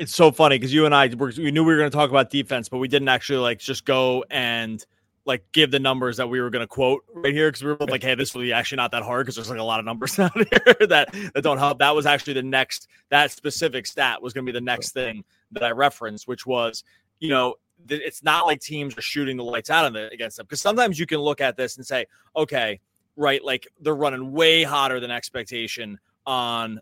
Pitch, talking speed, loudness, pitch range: 135 Hz, 260 wpm, -21 LUFS, 120-150 Hz